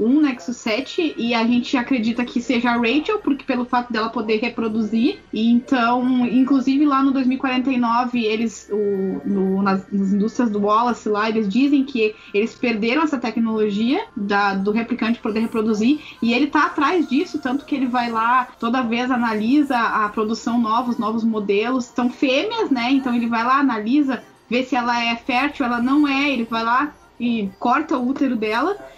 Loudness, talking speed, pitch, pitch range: -20 LUFS, 180 wpm, 240 Hz, 225-270 Hz